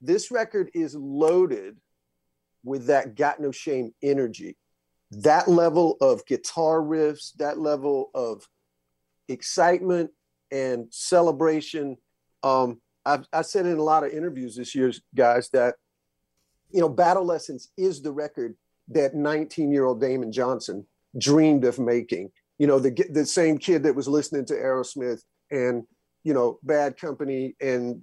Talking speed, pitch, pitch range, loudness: 145 wpm, 140 Hz, 120-160 Hz, -24 LUFS